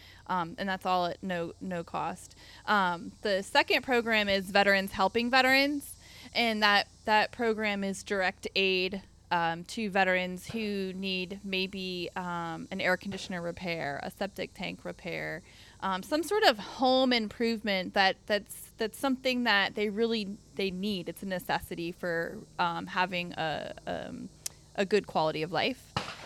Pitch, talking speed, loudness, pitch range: 195 Hz, 150 wpm, -30 LUFS, 180-215 Hz